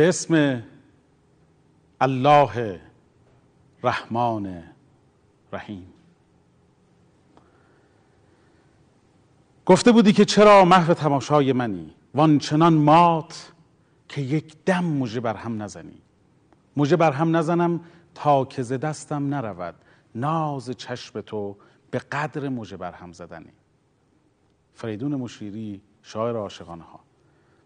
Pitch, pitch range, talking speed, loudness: 135 Hz, 110-155 Hz, 95 wpm, -21 LUFS